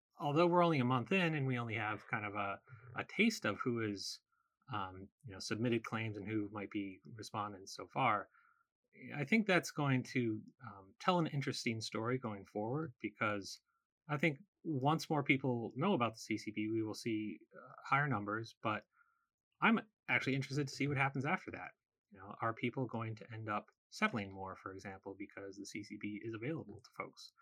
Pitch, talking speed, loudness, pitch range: 120 Hz, 190 wpm, -38 LUFS, 105-150 Hz